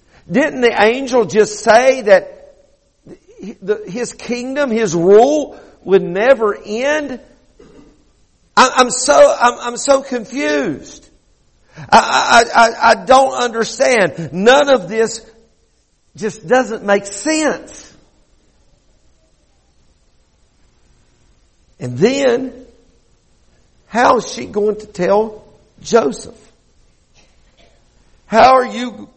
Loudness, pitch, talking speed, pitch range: -13 LUFS, 225 Hz, 85 wpm, 195-255 Hz